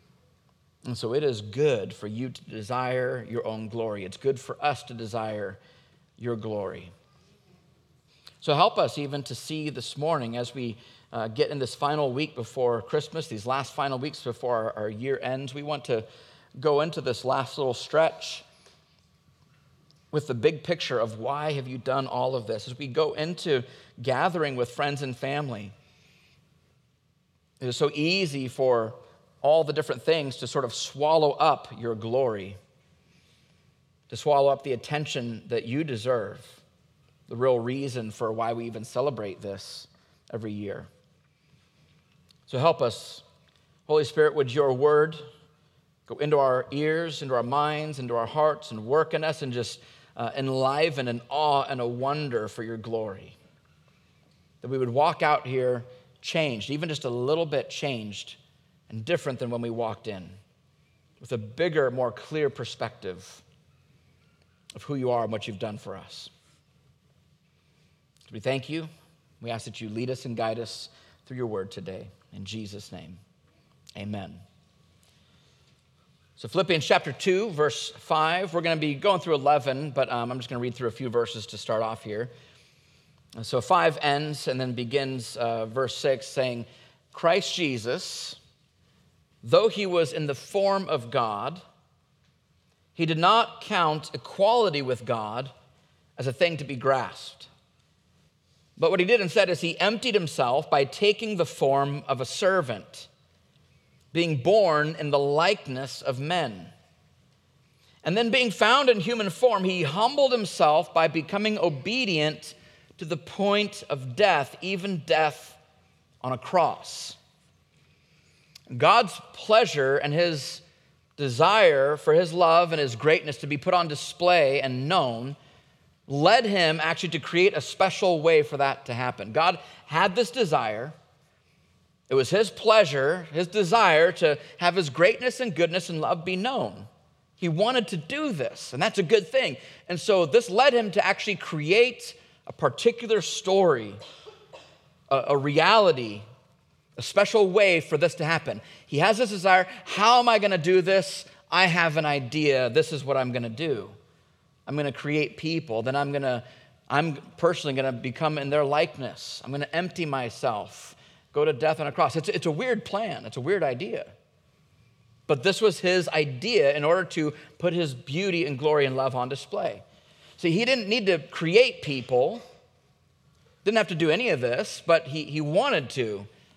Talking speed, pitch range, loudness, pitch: 165 wpm, 125-170 Hz, -25 LUFS, 145 Hz